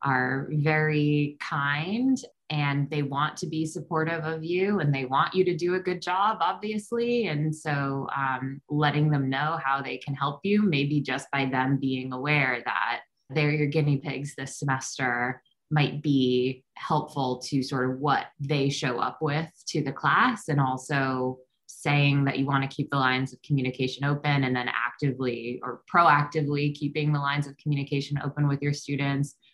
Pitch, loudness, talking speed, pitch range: 145 Hz, -27 LUFS, 175 wpm, 135-155 Hz